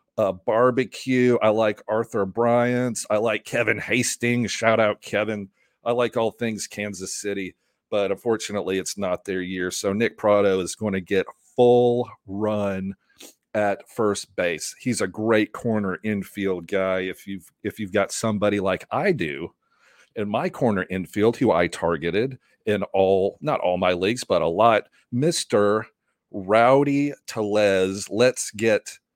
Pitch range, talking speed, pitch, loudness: 95-120 Hz, 150 wpm, 105 Hz, -23 LUFS